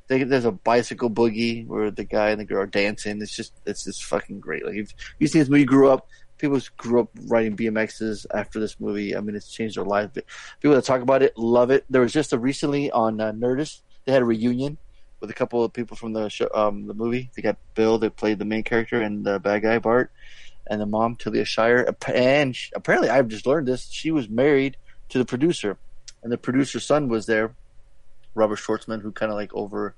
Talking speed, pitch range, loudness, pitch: 230 wpm, 110-130 Hz, -23 LUFS, 115 Hz